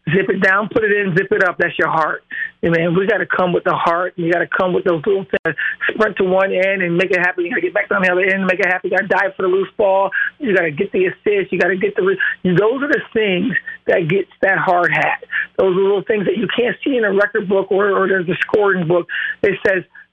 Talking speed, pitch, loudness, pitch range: 300 wpm, 195 Hz, -16 LUFS, 185-240 Hz